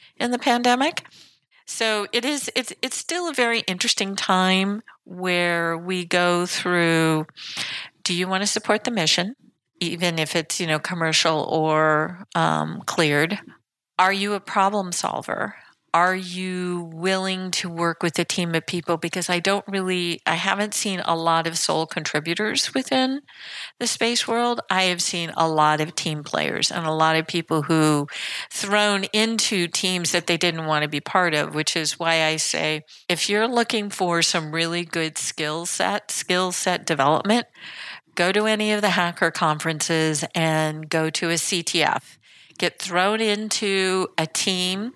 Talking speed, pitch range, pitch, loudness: 165 wpm, 165-205 Hz, 180 Hz, -22 LUFS